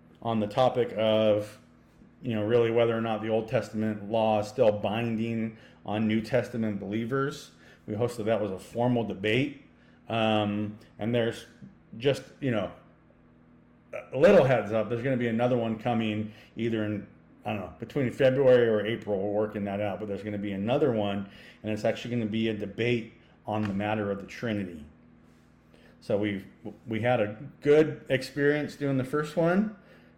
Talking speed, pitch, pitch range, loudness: 180 wpm, 110 Hz, 105-120 Hz, -28 LUFS